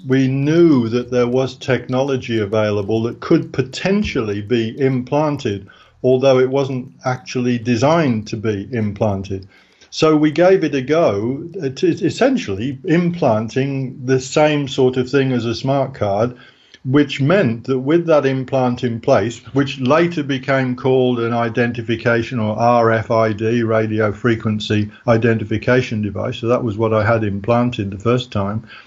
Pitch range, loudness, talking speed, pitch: 115-135 Hz, -17 LUFS, 140 wpm, 125 Hz